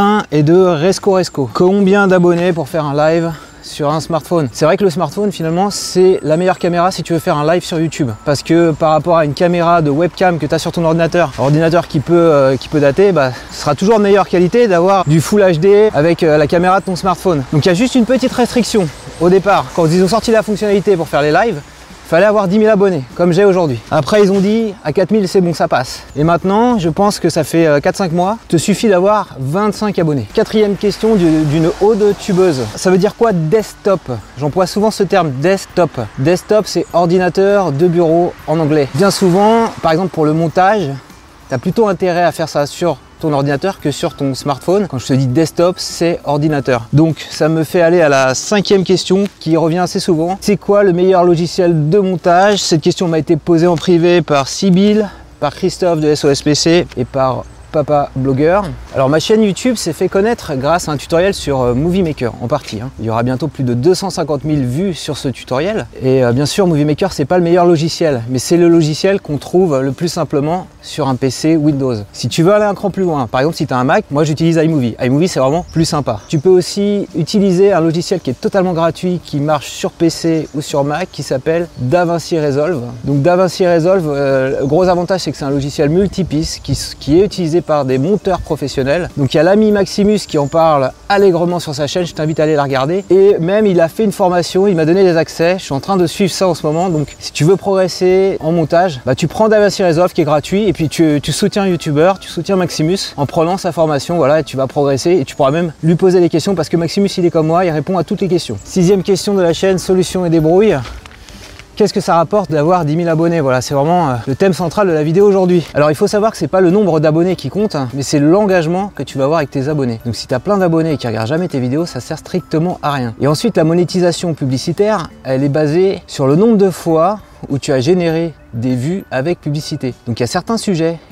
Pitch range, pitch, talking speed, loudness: 150-190 Hz, 170 Hz, 235 wpm, -13 LUFS